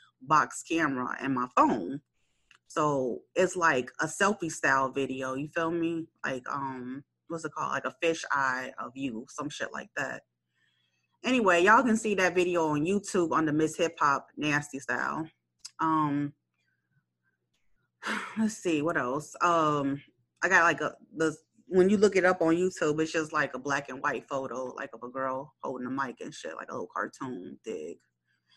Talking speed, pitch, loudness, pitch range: 180 wpm, 150 Hz, -29 LUFS, 130-170 Hz